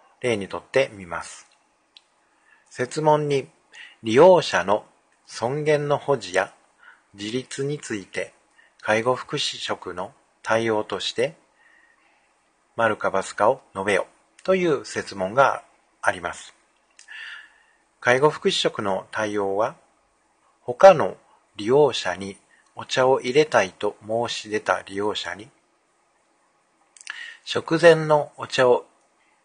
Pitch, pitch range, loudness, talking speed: 135 Hz, 110-170 Hz, -22 LUFS, 200 characters per minute